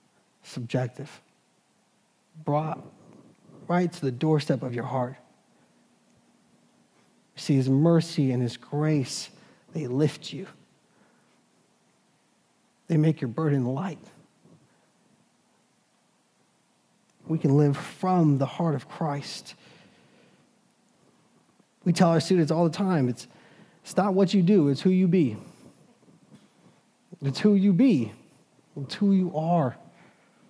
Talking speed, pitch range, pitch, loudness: 110 wpm, 140-185 Hz, 160 Hz, -25 LUFS